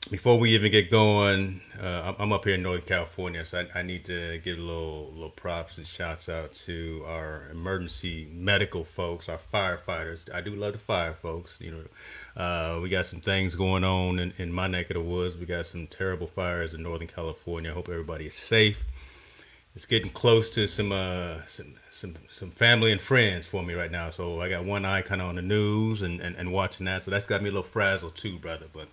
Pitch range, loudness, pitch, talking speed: 85-100 Hz, -28 LUFS, 90 Hz, 225 wpm